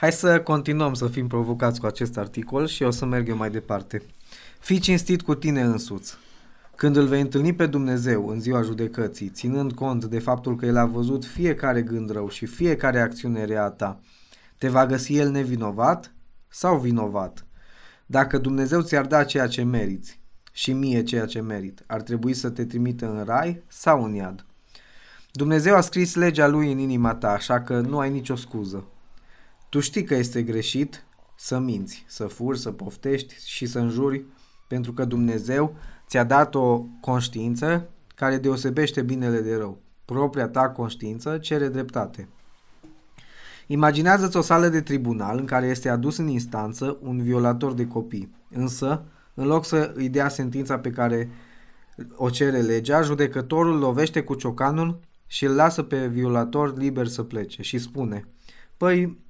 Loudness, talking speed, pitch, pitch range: -24 LUFS, 165 wpm, 130 Hz, 115-145 Hz